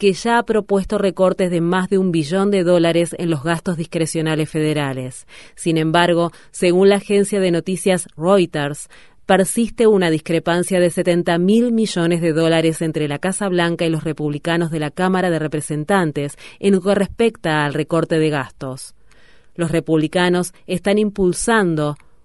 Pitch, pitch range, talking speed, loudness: 170 Hz, 160-190 Hz, 155 wpm, -18 LUFS